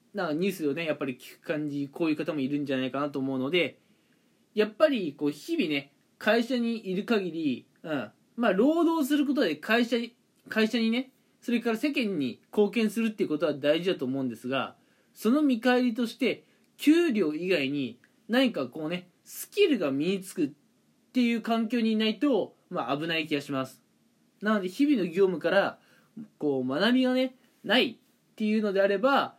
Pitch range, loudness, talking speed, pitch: 155-255 Hz, -28 LUFS, 350 characters per minute, 215 Hz